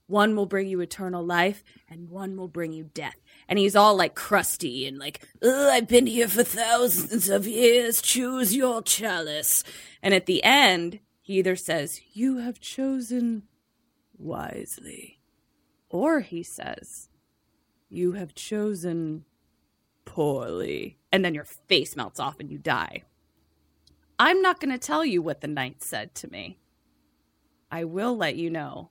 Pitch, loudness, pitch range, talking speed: 190 Hz, -24 LUFS, 155-235 Hz, 155 wpm